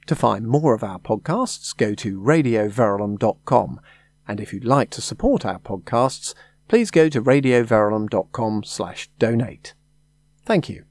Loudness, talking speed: -21 LUFS, 130 wpm